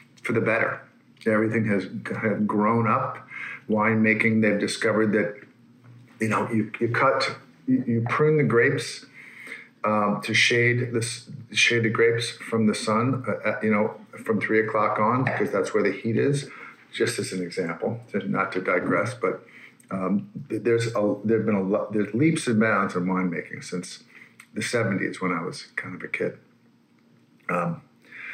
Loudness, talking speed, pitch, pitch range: -24 LUFS, 170 wpm, 110 Hz, 105-120 Hz